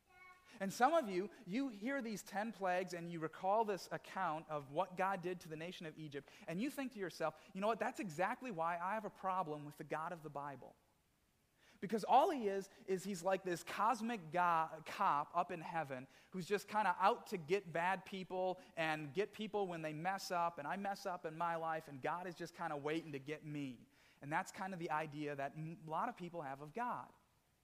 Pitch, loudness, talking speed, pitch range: 180 Hz, -41 LUFS, 230 wpm, 160-200 Hz